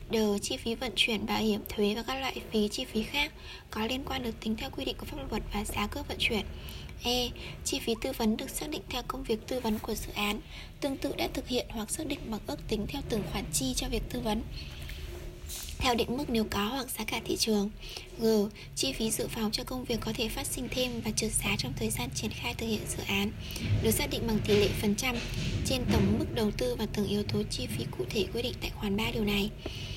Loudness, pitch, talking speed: -32 LUFS, 215 Hz, 260 wpm